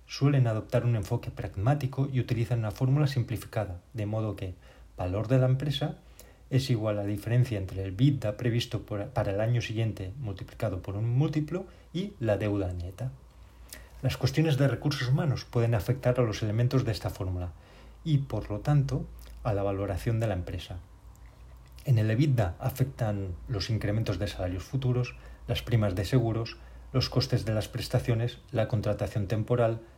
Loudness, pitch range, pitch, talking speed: -30 LUFS, 100-125 Hz, 115 Hz, 165 wpm